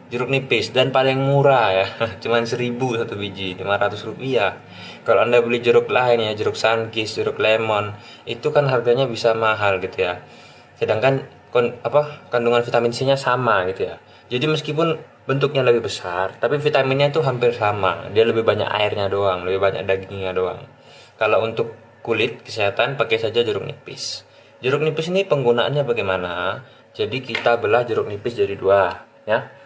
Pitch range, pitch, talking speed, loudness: 105-140 Hz, 120 Hz, 160 wpm, -20 LUFS